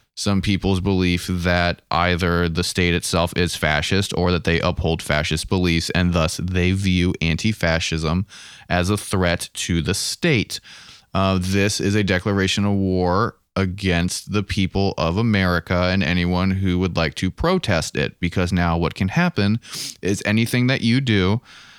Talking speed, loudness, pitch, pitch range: 160 wpm, -20 LUFS, 90 Hz, 85-100 Hz